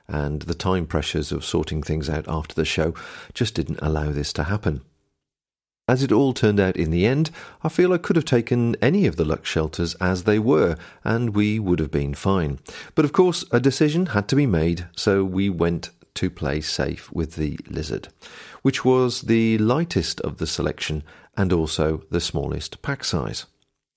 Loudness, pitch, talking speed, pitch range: -23 LUFS, 95 Hz, 190 wpm, 80-120 Hz